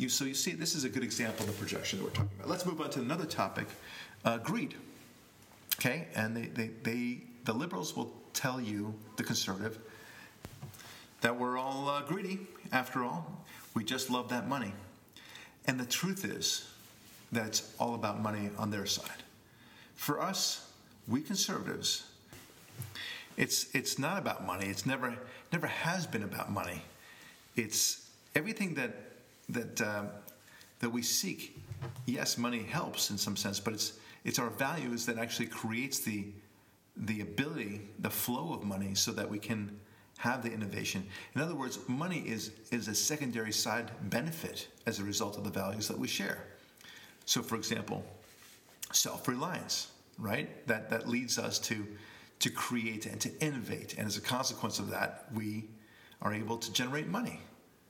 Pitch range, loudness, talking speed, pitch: 105-125 Hz, -35 LUFS, 165 wpm, 115 Hz